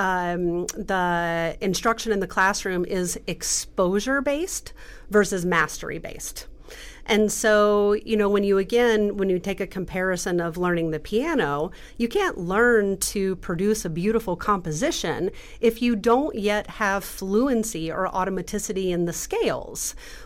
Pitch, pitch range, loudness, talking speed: 195 Hz, 180-215 Hz, -24 LUFS, 140 wpm